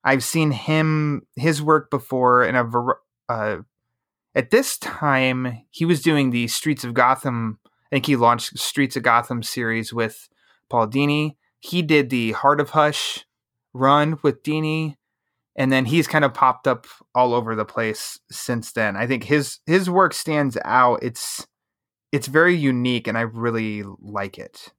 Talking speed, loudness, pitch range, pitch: 165 wpm, -20 LUFS, 120-150 Hz, 135 Hz